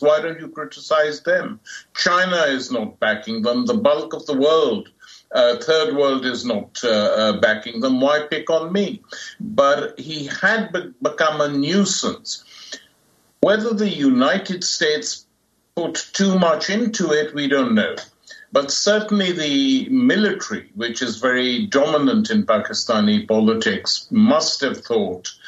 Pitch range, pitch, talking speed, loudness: 145-215 Hz, 175 Hz, 145 wpm, -19 LUFS